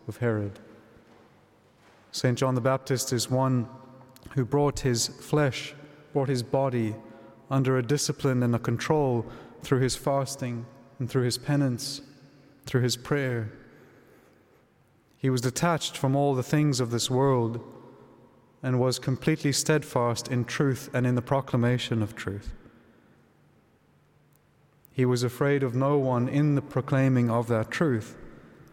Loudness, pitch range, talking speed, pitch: -27 LUFS, 120-140 Hz, 135 wpm, 130 Hz